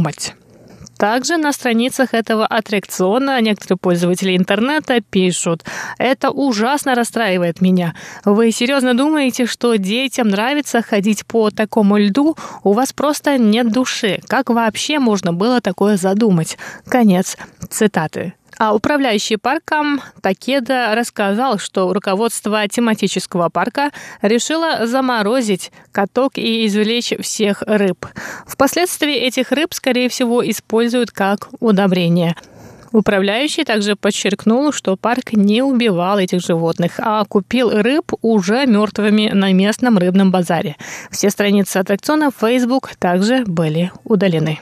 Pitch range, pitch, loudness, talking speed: 195-250 Hz, 220 Hz, -16 LUFS, 115 wpm